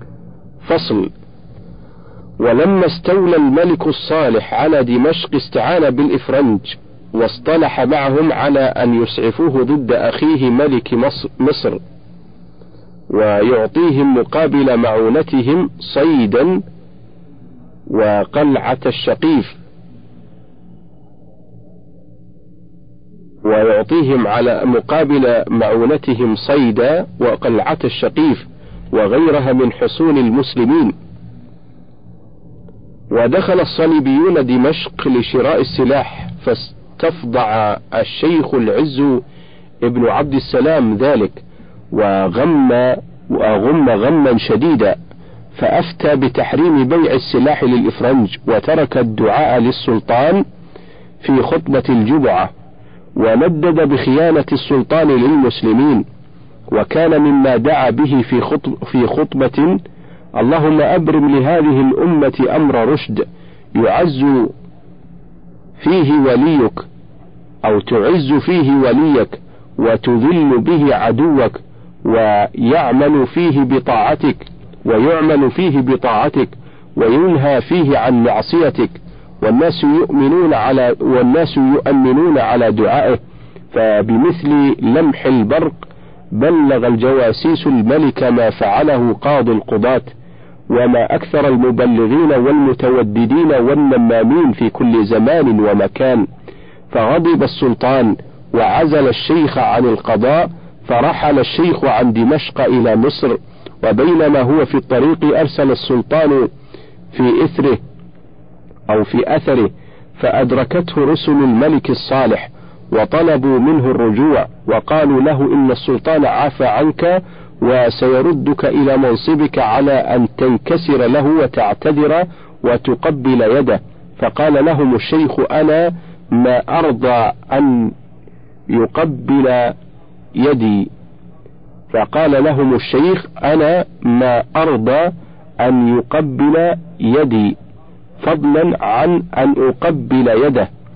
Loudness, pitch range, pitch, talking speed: -13 LUFS, 105-155 Hz, 130 Hz, 85 wpm